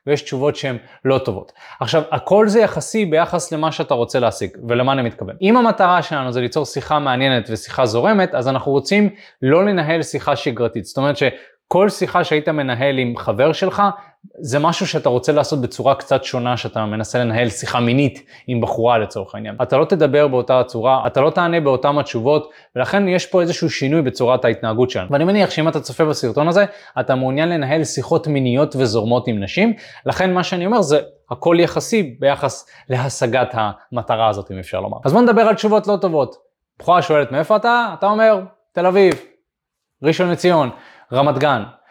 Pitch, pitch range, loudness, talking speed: 145 Hz, 125-180 Hz, -17 LUFS, 180 wpm